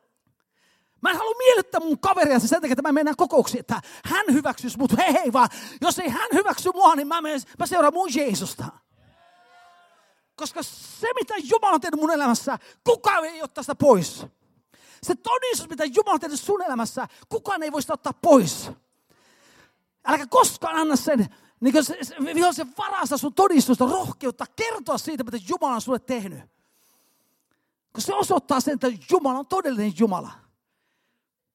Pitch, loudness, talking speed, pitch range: 310 Hz, -22 LUFS, 170 wpm, 265-360 Hz